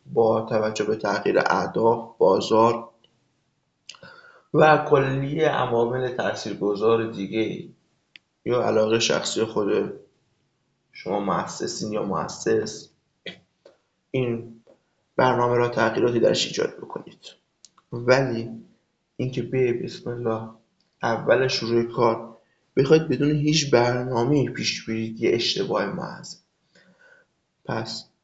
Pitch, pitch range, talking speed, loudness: 120 Hz, 115-135 Hz, 95 wpm, -23 LUFS